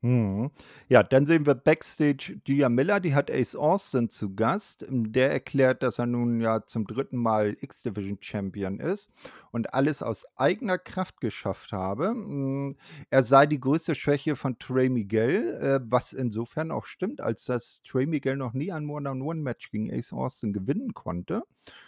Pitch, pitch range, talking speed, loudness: 130 Hz, 115-150 Hz, 165 wpm, -27 LUFS